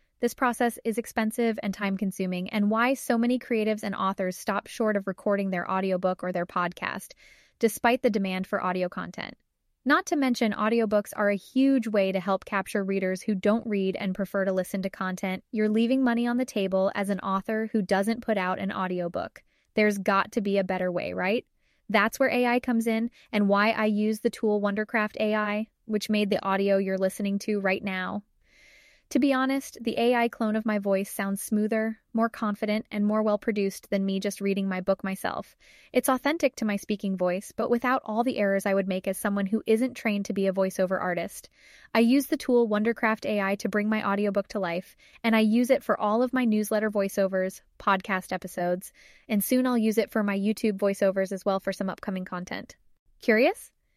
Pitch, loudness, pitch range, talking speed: 210 Hz, -27 LUFS, 195-230 Hz, 205 wpm